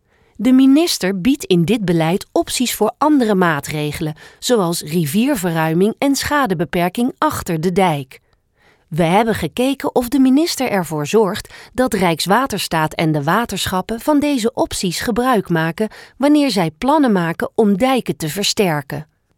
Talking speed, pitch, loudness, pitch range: 135 wpm, 200 Hz, -17 LUFS, 170-255 Hz